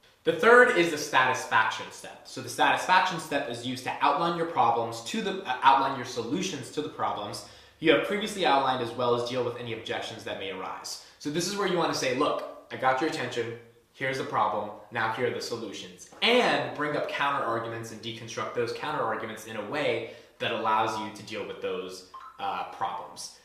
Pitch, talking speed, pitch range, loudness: 140 Hz, 205 wpm, 115-195 Hz, -28 LUFS